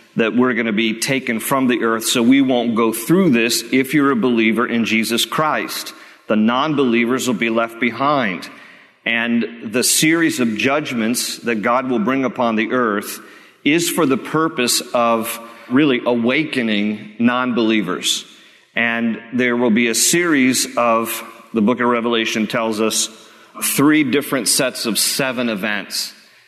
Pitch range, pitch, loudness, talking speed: 115-130 Hz, 120 Hz, -17 LUFS, 155 wpm